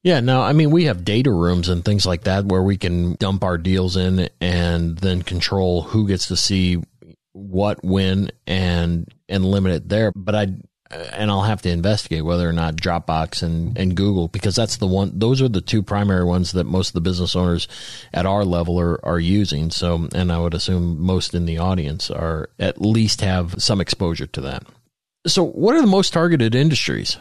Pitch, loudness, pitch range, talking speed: 95 Hz, -19 LUFS, 85-100 Hz, 205 wpm